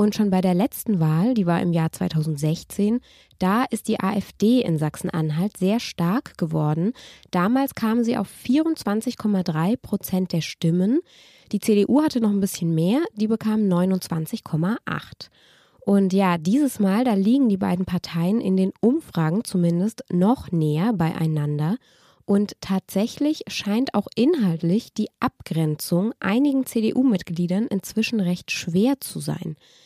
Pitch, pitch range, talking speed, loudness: 200 Hz, 175-225 Hz, 135 wpm, -22 LUFS